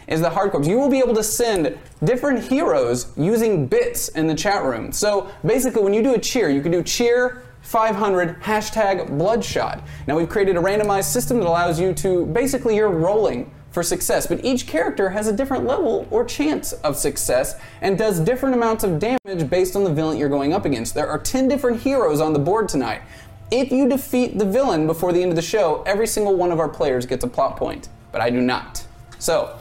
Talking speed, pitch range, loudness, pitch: 215 wpm, 165-245 Hz, -20 LUFS, 200 Hz